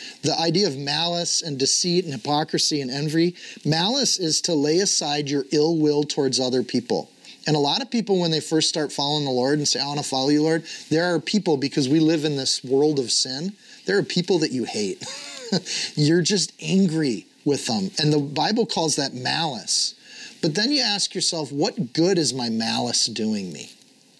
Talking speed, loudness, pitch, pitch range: 200 wpm, -22 LUFS, 155 Hz, 145-175 Hz